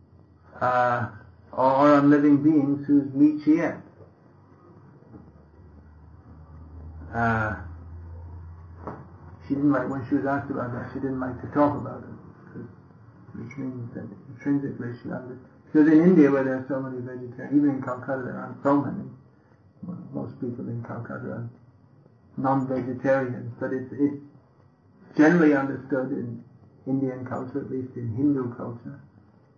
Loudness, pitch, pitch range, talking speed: -24 LUFS, 130 Hz, 105-140 Hz, 140 wpm